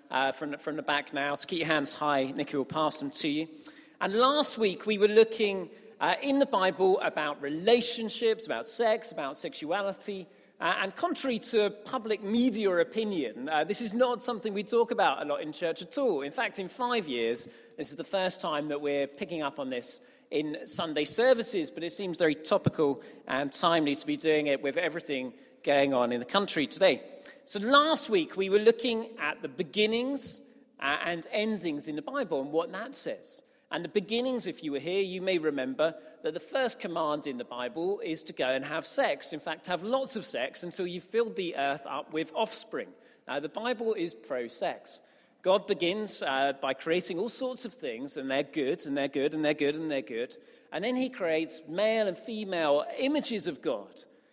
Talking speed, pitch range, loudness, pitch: 205 wpm, 155-235 Hz, -30 LUFS, 190 Hz